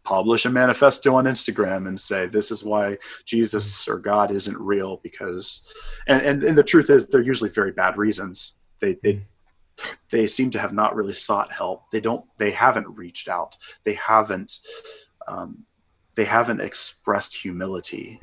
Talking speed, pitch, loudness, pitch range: 165 wpm, 105 Hz, -21 LUFS, 95-130 Hz